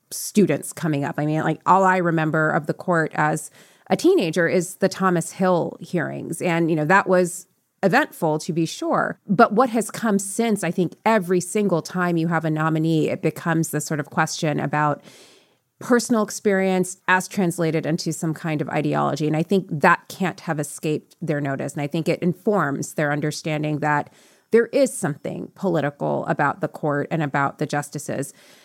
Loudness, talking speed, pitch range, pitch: -22 LUFS, 180 wpm, 155-185 Hz, 165 Hz